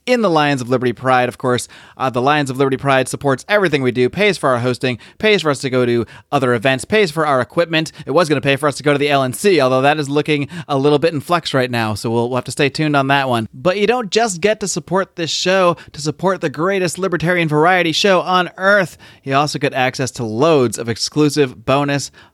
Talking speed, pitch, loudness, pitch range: 255 wpm, 145 Hz, -16 LUFS, 130-175 Hz